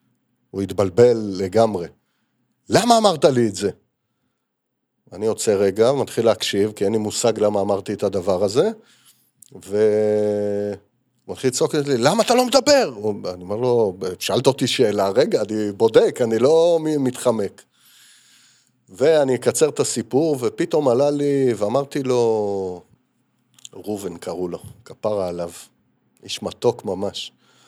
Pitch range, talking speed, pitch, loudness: 105-150 Hz, 130 wpm, 115 Hz, -20 LUFS